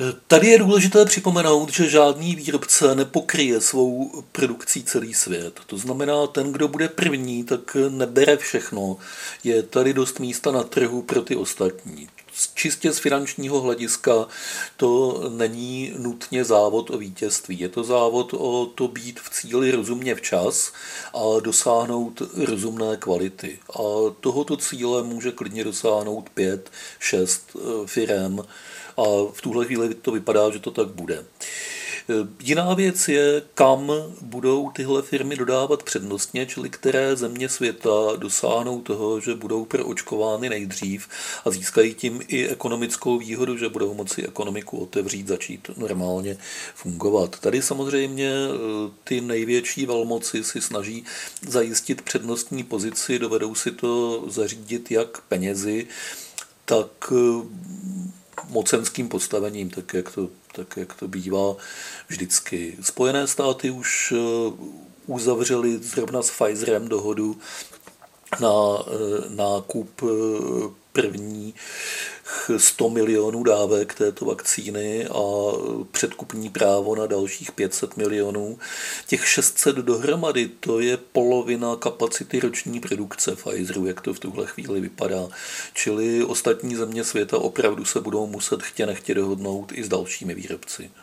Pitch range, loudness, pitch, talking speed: 105-130 Hz, -23 LUFS, 120 Hz, 125 wpm